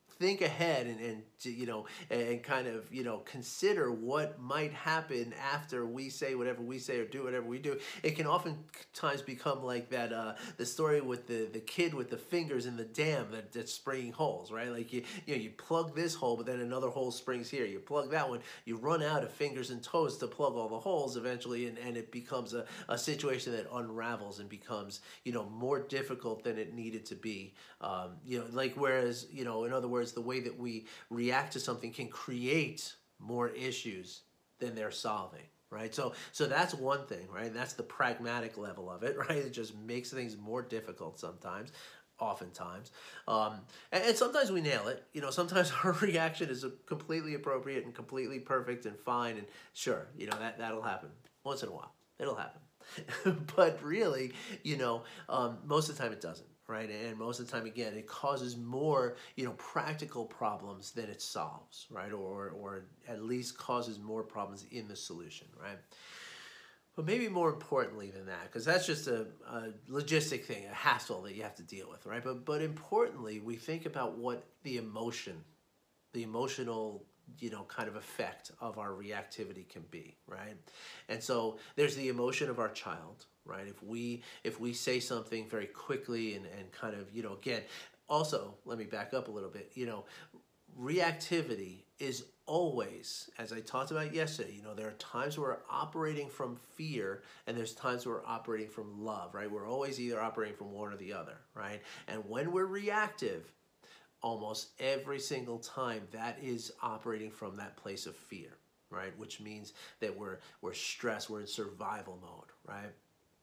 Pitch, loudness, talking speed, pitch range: 120 Hz, -38 LUFS, 190 wpm, 110-140 Hz